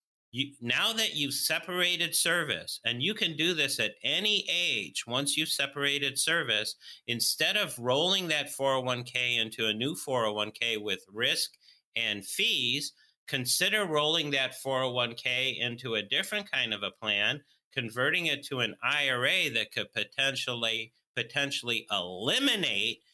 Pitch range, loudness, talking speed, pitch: 120-160 Hz, -28 LUFS, 135 wpm, 135 Hz